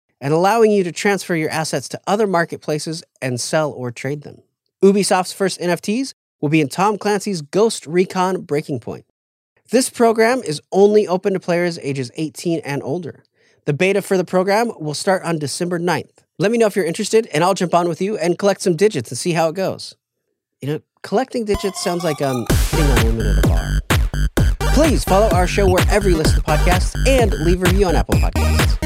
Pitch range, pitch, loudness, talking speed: 150-200 Hz, 175 Hz, -18 LUFS, 205 wpm